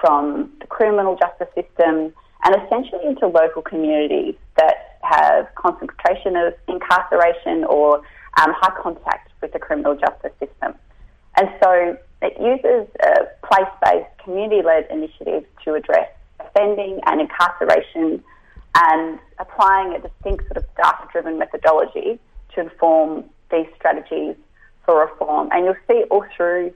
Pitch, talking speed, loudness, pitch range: 190 Hz, 125 wpm, -18 LUFS, 165-230 Hz